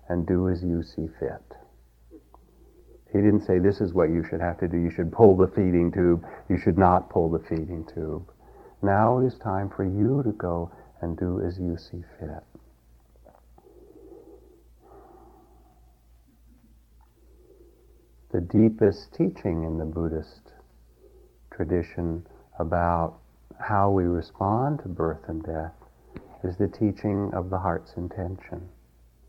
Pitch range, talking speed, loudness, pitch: 80-100 Hz, 135 wpm, -26 LUFS, 90 Hz